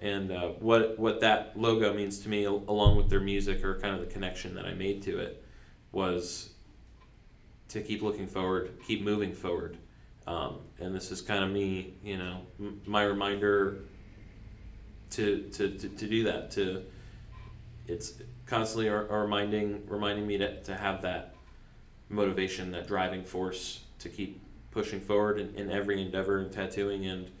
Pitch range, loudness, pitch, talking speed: 95-105 Hz, -32 LUFS, 100 Hz, 165 wpm